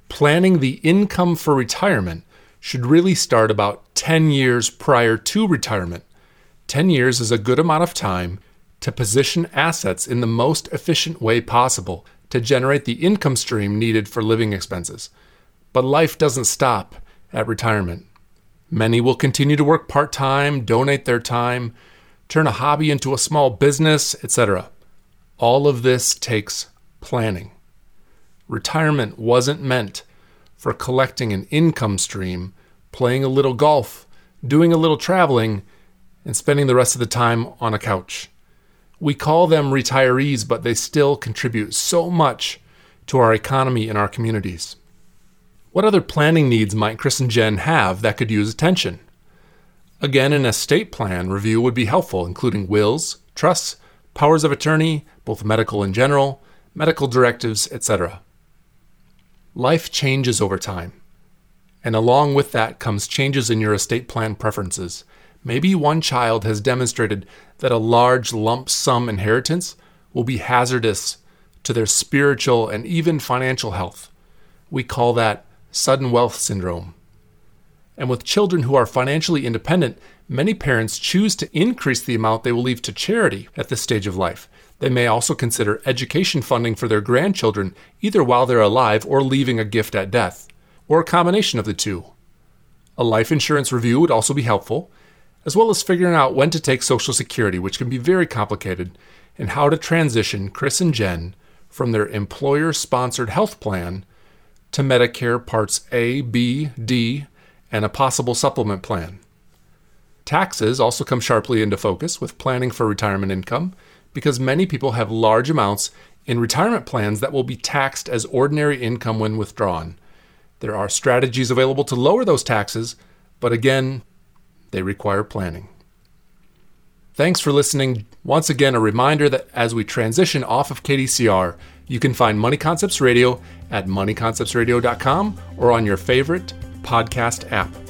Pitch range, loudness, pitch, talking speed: 110-140 Hz, -18 LUFS, 125 Hz, 155 wpm